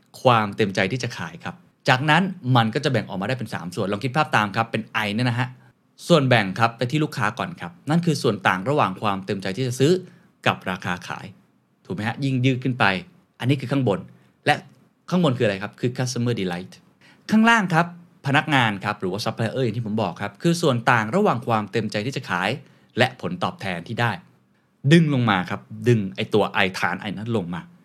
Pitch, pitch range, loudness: 120 Hz, 105-140 Hz, -22 LUFS